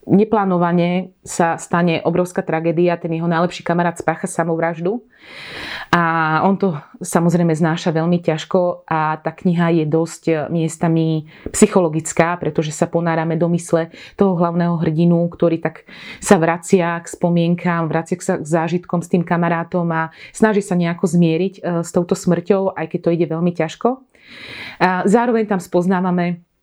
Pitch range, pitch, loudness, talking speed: 165-185 Hz, 170 Hz, -18 LUFS, 145 wpm